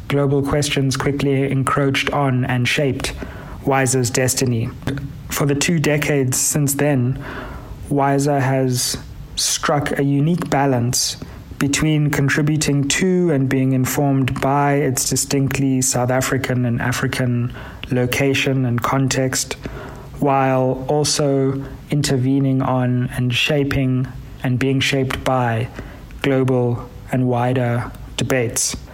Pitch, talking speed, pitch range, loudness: 135 Hz, 105 wpm, 130-140 Hz, -18 LUFS